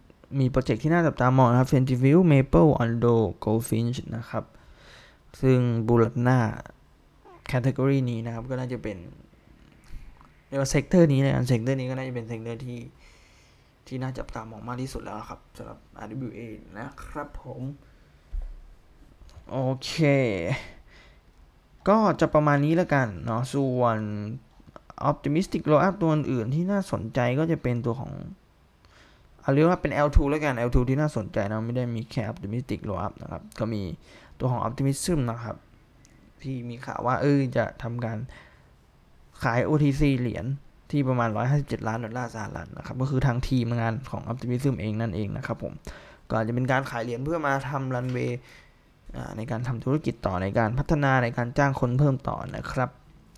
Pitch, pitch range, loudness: 125 Hz, 115-140 Hz, -26 LUFS